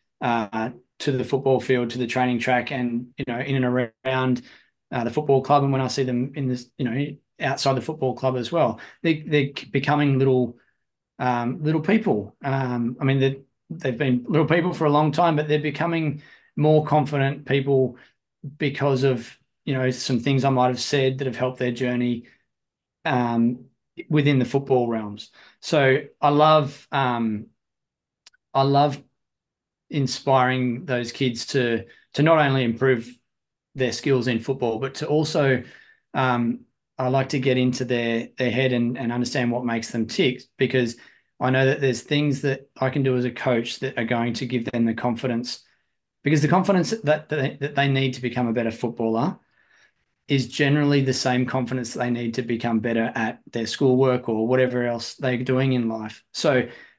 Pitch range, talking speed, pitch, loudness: 120-140 Hz, 180 wpm, 130 Hz, -23 LUFS